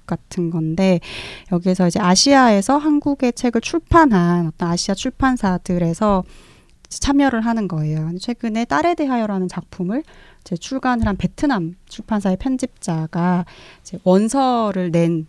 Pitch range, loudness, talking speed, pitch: 175-255 Hz, -18 LUFS, 290 characters per minute, 195 Hz